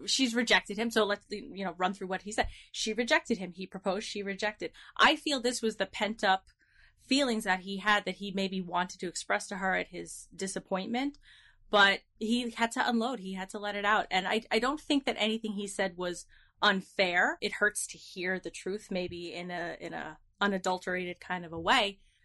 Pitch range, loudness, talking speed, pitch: 185-220 Hz, -31 LUFS, 215 wpm, 195 Hz